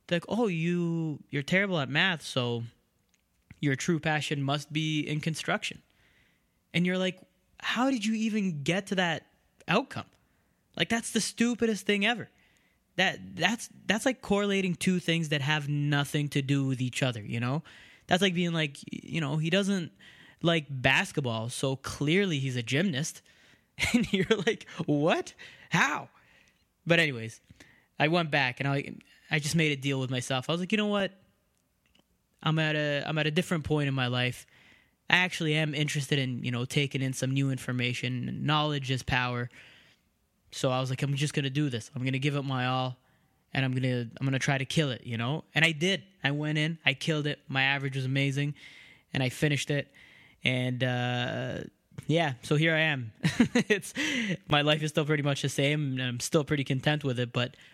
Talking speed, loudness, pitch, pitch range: 190 wpm, -29 LUFS, 150 Hz, 130-170 Hz